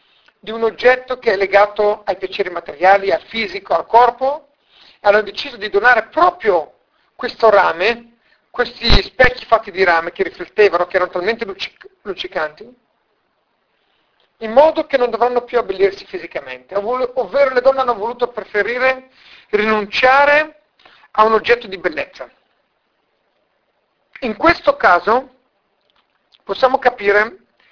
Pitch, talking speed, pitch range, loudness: 235 Hz, 125 wpm, 205-265 Hz, -16 LUFS